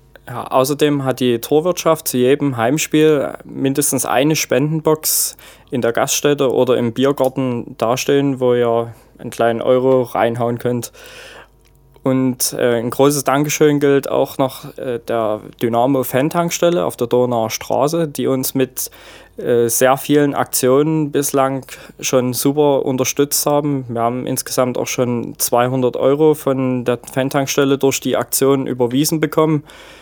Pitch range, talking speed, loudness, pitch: 125-145 Hz, 135 wpm, -16 LUFS, 135 Hz